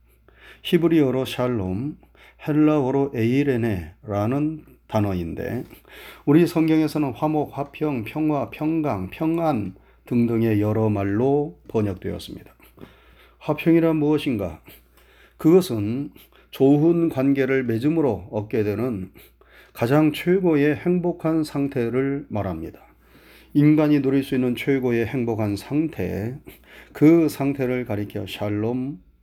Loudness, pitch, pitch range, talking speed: -22 LUFS, 135 Hz, 105-150 Hz, 240 characters per minute